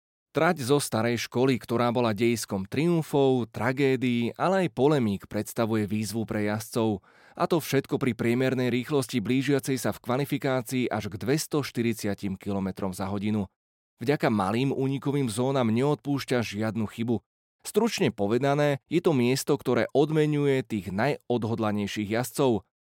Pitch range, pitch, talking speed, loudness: 110-140 Hz, 125 Hz, 130 wpm, -27 LUFS